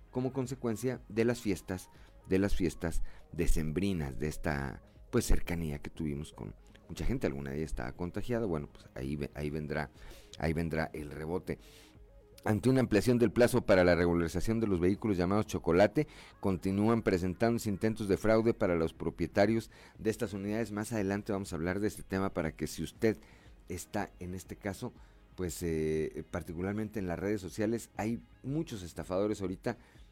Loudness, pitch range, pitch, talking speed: -33 LUFS, 85-110 Hz, 95 Hz, 165 wpm